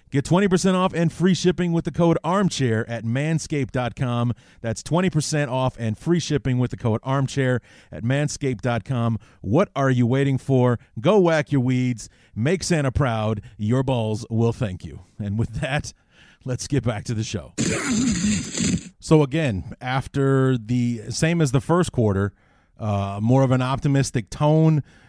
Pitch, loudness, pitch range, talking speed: 130 Hz, -22 LUFS, 115-150 Hz, 155 wpm